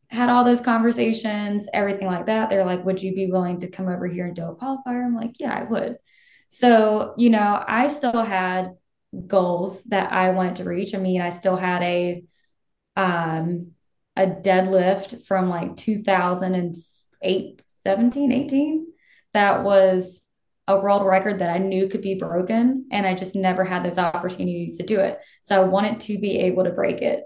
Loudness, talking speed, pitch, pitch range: -22 LUFS, 180 wpm, 190 Hz, 180-215 Hz